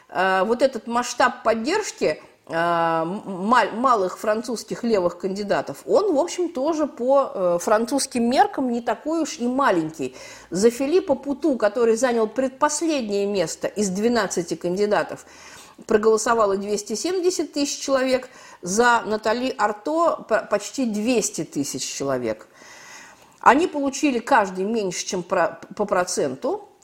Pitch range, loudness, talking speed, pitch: 195-280 Hz, -22 LUFS, 105 wpm, 230 Hz